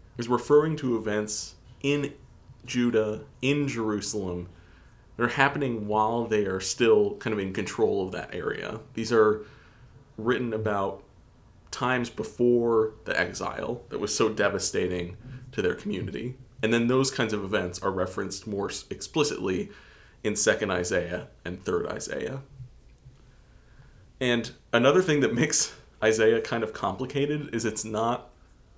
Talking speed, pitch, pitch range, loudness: 135 wpm, 115 Hz, 105-125 Hz, -27 LUFS